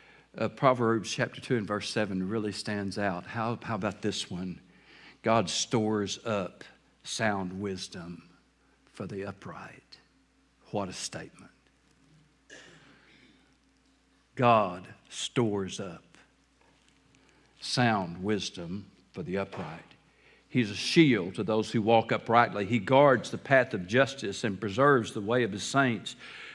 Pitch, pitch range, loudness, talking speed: 105 Hz, 95-120 Hz, -29 LUFS, 125 wpm